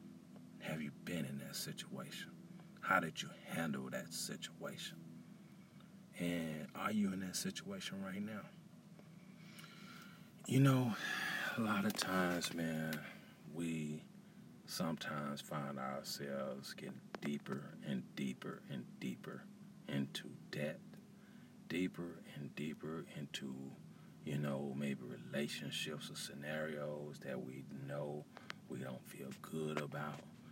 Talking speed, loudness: 110 wpm, -43 LUFS